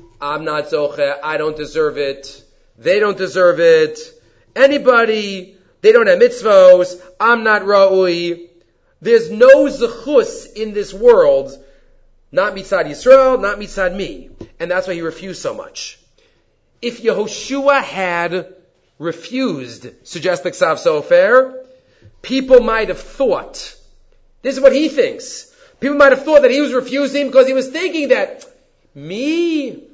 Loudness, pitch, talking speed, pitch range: -14 LUFS, 240 Hz, 135 wpm, 180-285 Hz